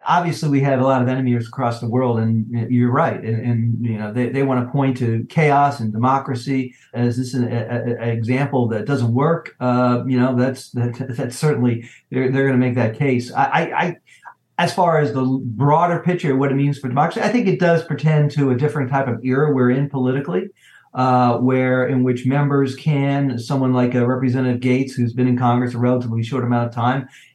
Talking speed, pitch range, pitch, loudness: 215 wpm, 120-140 Hz, 130 Hz, -19 LUFS